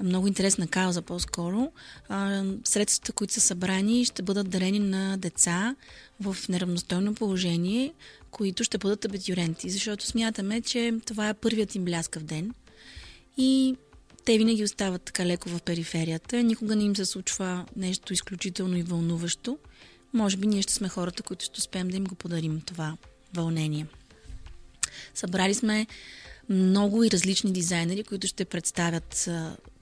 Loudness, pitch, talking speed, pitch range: -27 LUFS, 195 Hz, 145 wpm, 180-215 Hz